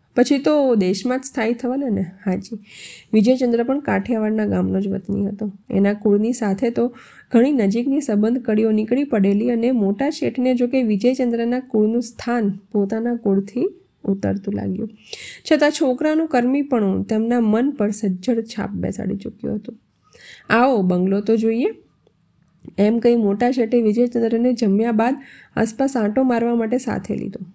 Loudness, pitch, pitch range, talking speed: -20 LUFS, 230 Hz, 210-250 Hz, 140 wpm